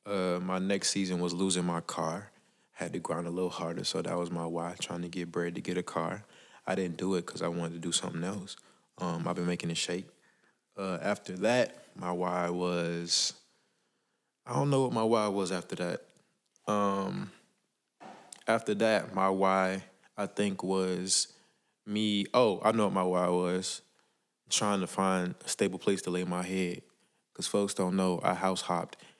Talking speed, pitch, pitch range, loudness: 190 wpm, 90 Hz, 90-95 Hz, -32 LUFS